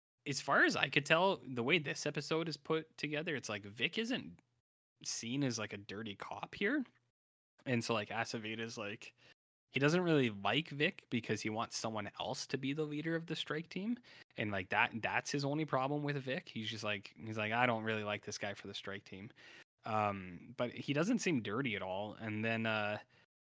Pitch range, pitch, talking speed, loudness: 105-150 Hz, 125 Hz, 210 wpm, -37 LUFS